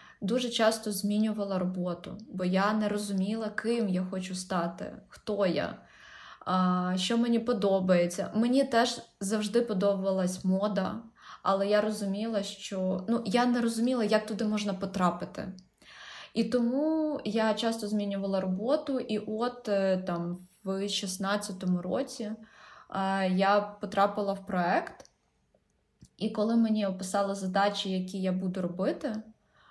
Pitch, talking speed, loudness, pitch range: 205 Hz, 120 wpm, -30 LUFS, 190-220 Hz